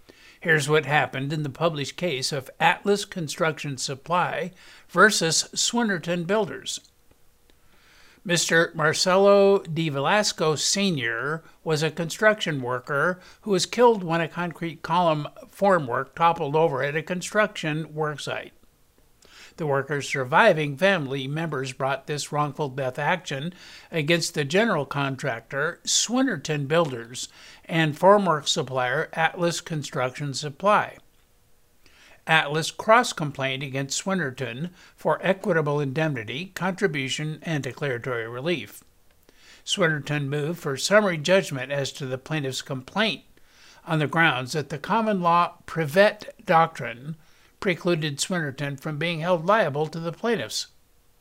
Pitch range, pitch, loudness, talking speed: 140-180 Hz, 160 Hz, -24 LUFS, 115 wpm